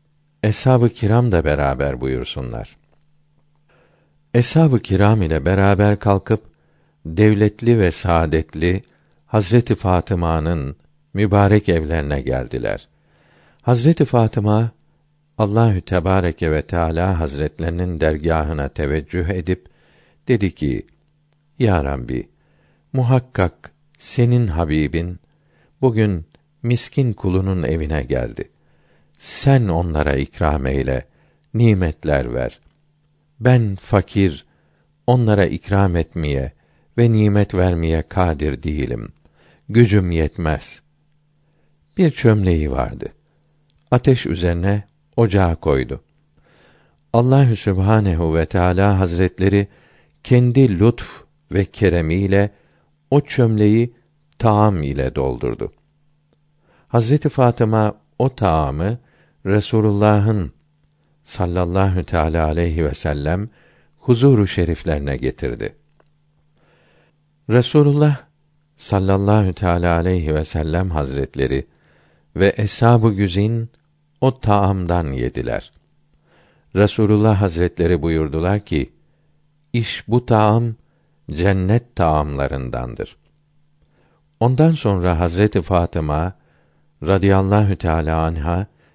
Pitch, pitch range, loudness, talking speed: 100 Hz, 80-120 Hz, -18 LUFS, 80 wpm